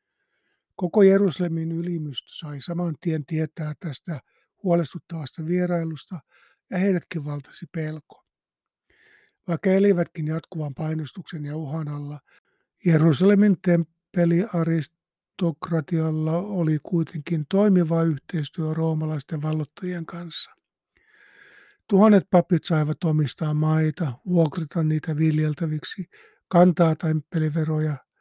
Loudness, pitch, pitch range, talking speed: -24 LUFS, 165 Hz, 155-180 Hz, 85 wpm